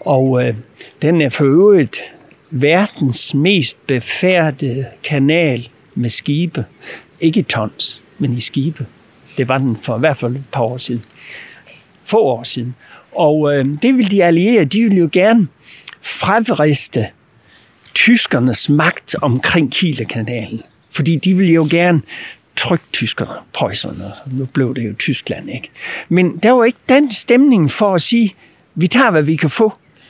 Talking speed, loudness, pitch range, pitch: 155 wpm, -14 LUFS, 125-180 Hz, 150 Hz